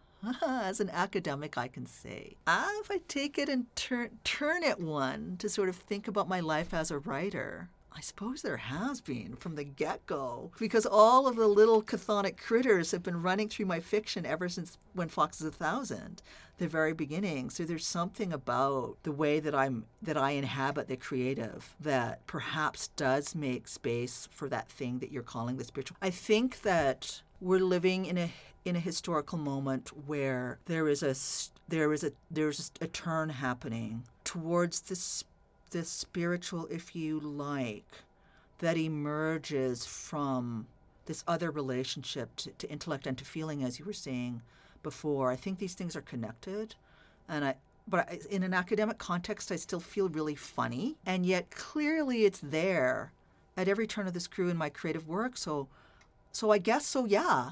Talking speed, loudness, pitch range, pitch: 175 wpm, -33 LUFS, 140-200 Hz, 165 Hz